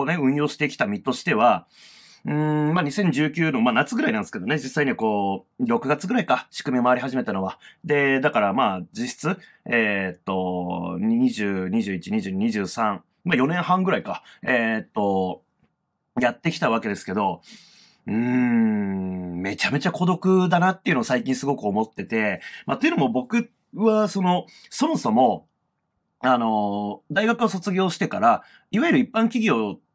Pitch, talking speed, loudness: 150 Hz, 290 characters per minute, -23 LUFS